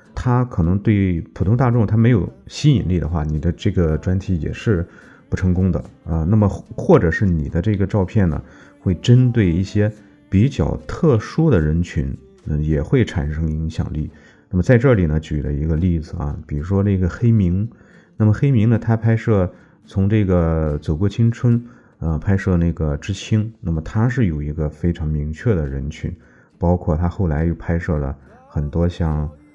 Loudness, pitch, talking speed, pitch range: -19 LUFS, 90 Hz, 265 characters per minute, 80-110 Hz